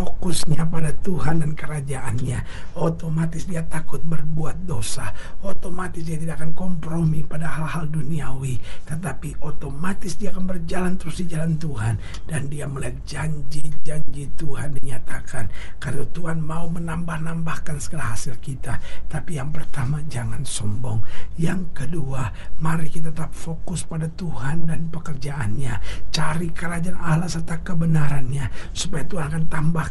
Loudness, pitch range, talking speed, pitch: -27 LUFS, 135-165 Hz, 130 wpm, 155 Hz